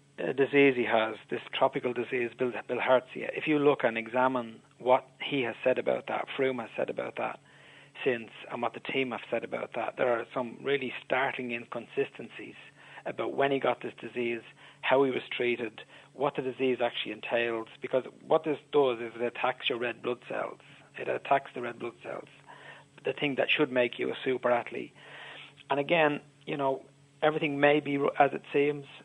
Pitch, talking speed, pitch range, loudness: 130 Hz, 190 wpm, 120-145 Hz, -30 LUFS